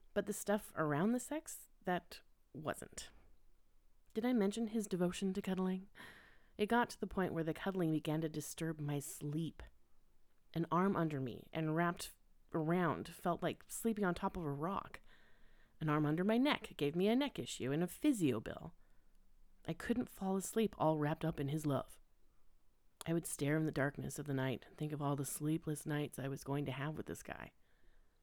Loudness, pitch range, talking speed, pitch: -39 LUFS, 150-195 Hz, 195 wpm, 165 Hz